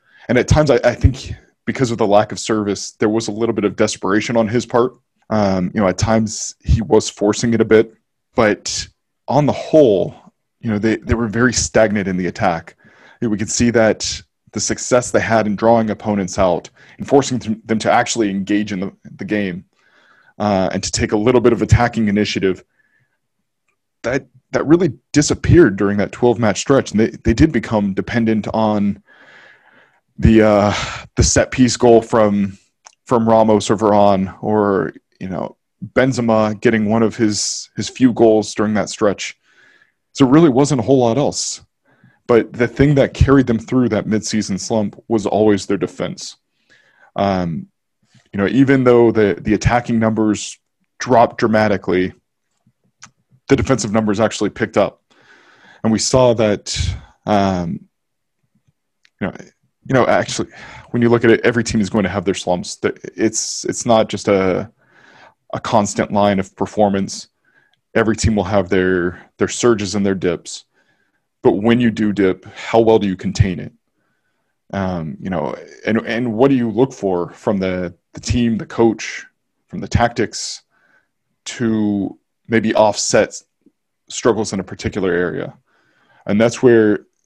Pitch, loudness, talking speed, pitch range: 110 Hz, -16 LUFS, 170 wpm, 100-115 Hz